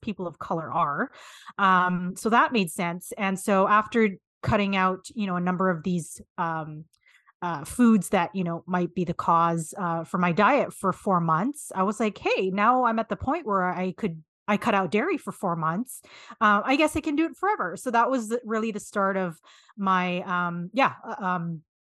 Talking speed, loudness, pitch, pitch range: 205 wpm, -25 LUFS, 190 Hz, 175-220 Hz